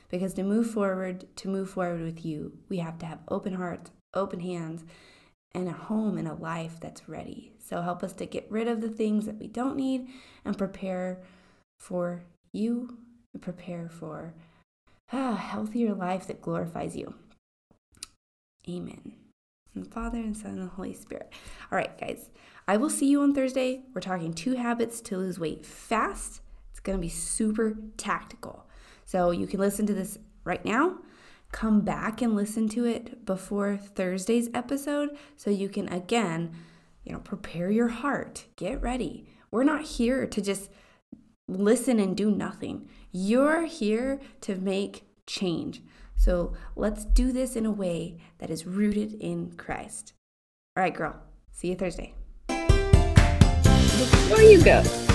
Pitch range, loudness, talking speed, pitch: 180-235 Hz, -27 LUFS, 160 wpm, 200 Hz